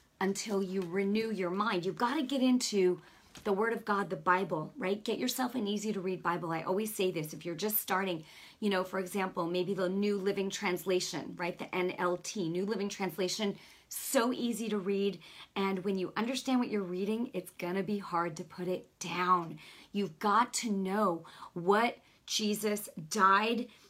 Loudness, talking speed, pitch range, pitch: -33 LUFS, 185 wpm, 180-215 Hz, 195 Hz